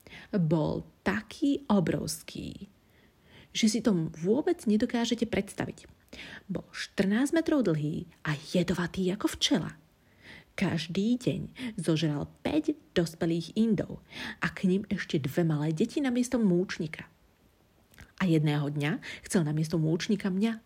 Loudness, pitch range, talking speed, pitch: -30 LUFS, 165-230 Hz, 120 wpm, 190 Hz